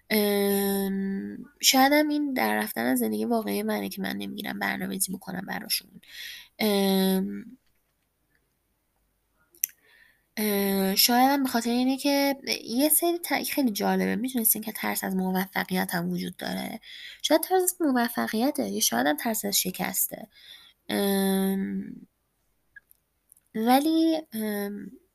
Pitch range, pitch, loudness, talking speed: 195-270 Hz, 215 Hz, -26 LUFS, 120 wpm